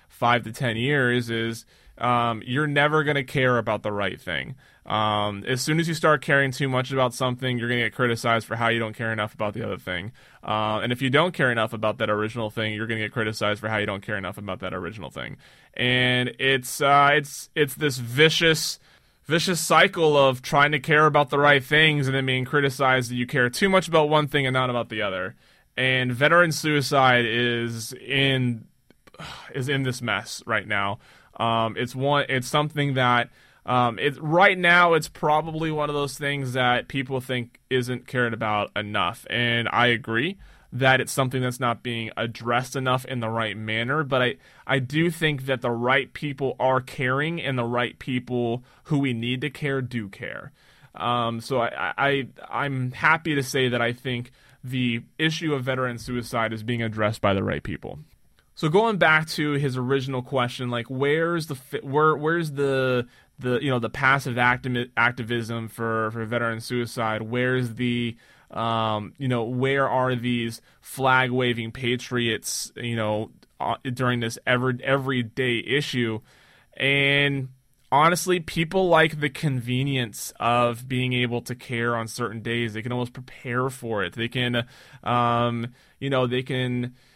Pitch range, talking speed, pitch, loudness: 120-140 Hz, 185 wpm, 125 Hz, -23 LUFS